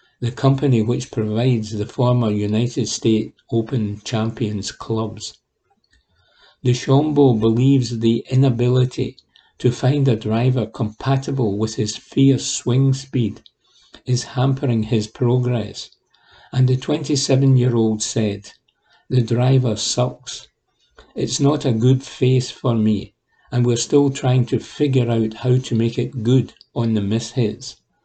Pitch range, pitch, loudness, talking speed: 110-130 Hz, 120 Hz, -19 LUFS, 125 wpm